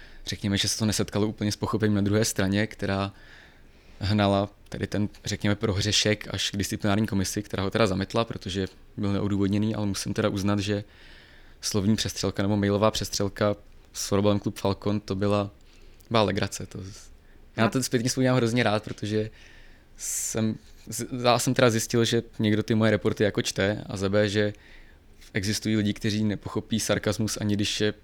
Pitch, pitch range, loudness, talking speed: 105 Hz, 100-110 Hz, -26 LUFS, 165 wpm